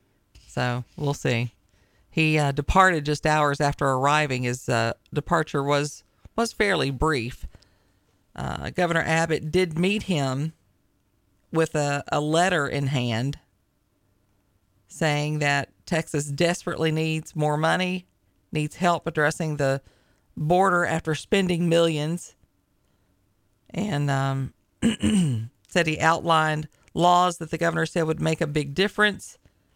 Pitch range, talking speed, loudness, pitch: 125-165 Hz, 120 wpm, -24 LUFS, 150 Hz